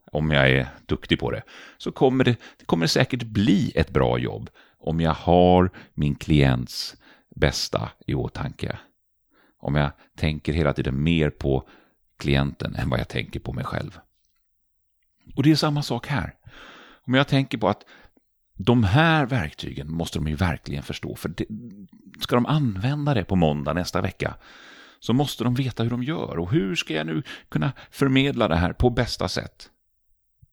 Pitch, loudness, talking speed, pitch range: 90 Hz, -24 LUFS, 170 wpm, 75-125 Hz